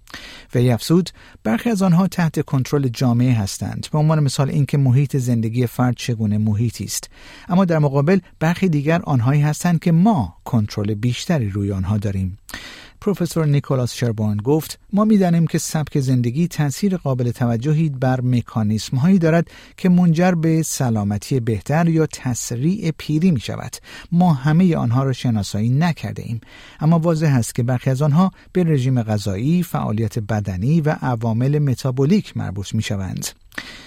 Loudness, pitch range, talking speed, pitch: -19 LUFS, 115-160 Hz, 150 wpm, 135 Hz